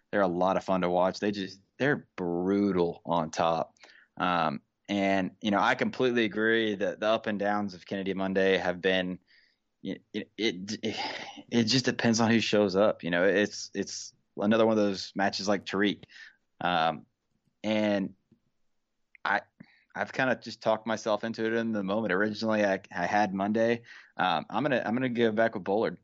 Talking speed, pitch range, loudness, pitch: 175 wpm, 95-110 Hz, -28 LUFS, 100 Hz